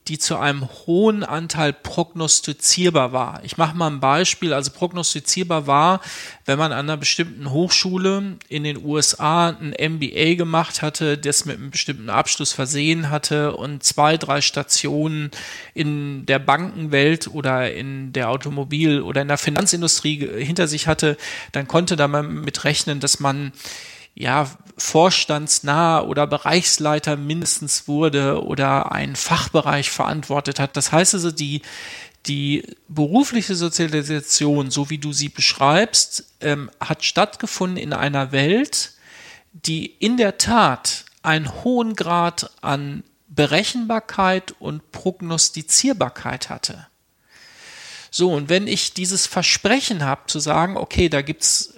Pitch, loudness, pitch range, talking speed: 155 Hz, -19 LUFS, 145-175 Hz, 135 wpm